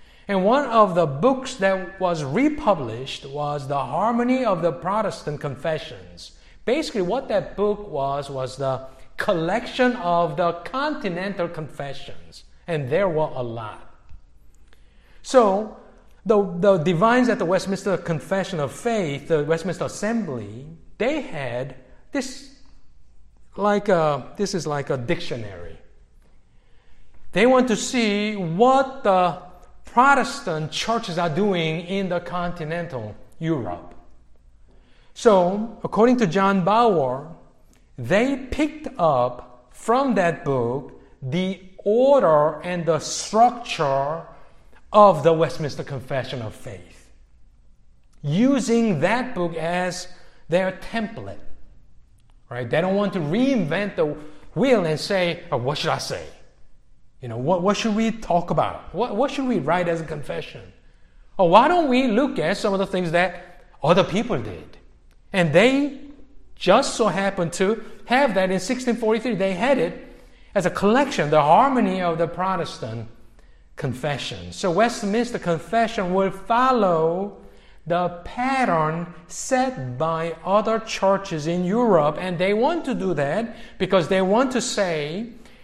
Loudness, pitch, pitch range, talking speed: -22 LUFS, 180 Hz, 150-220 Hz, 130 wpm